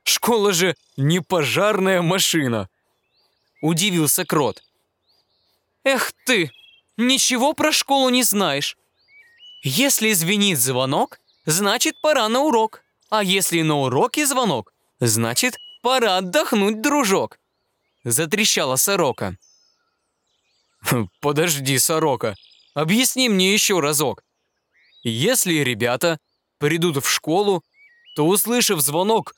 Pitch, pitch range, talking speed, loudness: 190 Hz, 150-245 Hz, 95 wpm, -19 LUFS